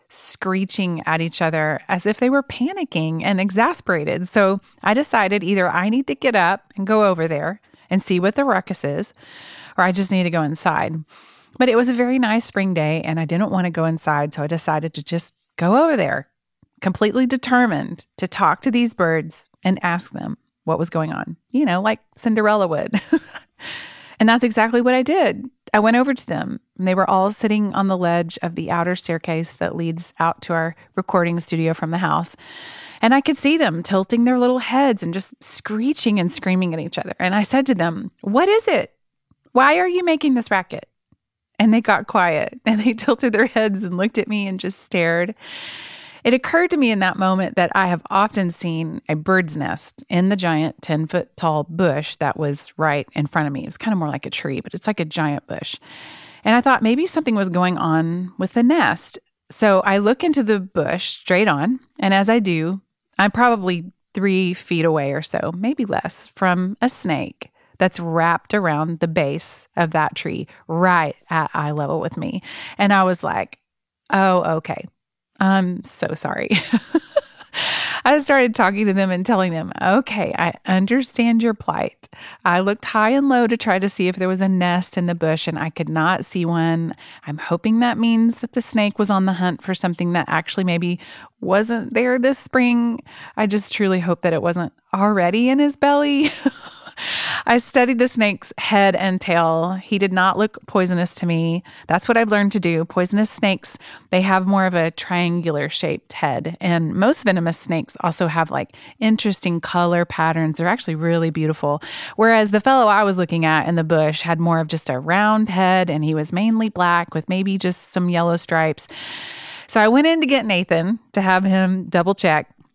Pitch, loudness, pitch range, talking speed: 190 Hz, -19 LUFS, 170-230 Hz, 200 wpm